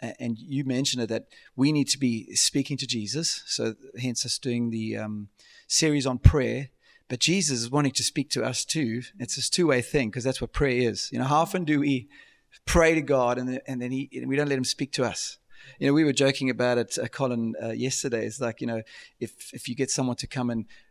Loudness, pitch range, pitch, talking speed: -26 LUFS, 120-140 Hz, 125 Hz, 235 wpm